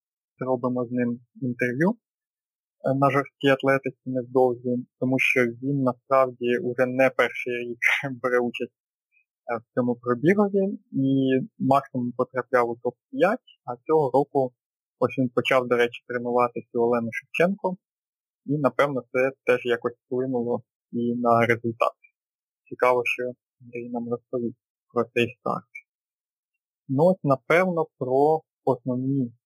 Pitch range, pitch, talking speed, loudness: 120-135 Hz, 125 Hz, 120 wpm, -24 LUFS